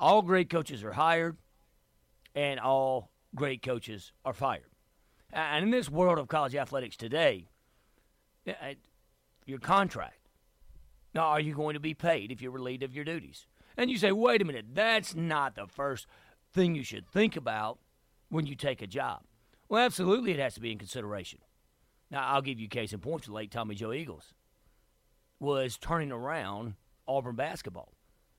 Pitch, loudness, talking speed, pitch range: 140 Hz, -31 LUFS, 165 wpm, 115-165 Hz